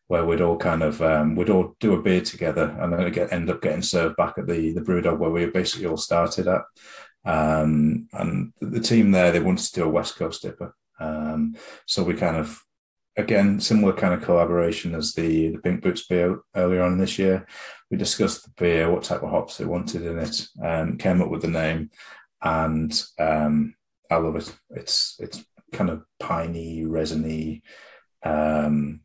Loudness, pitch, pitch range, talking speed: -23 LUFS, 80 Hz, 80-90 Hz, 195 wpm